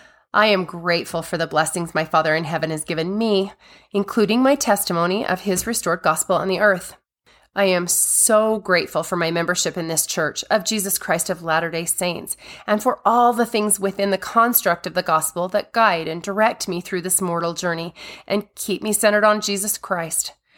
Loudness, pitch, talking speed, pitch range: -20 LUFS, 185 Hz, 195 wpm, 170-210 Hz